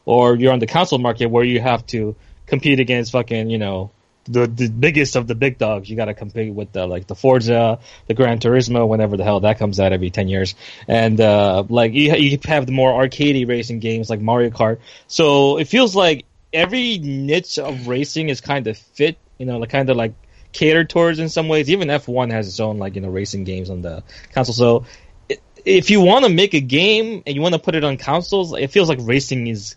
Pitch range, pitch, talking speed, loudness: 110-145 Hz, 125 Hz, 230 wpm, -17 LUFS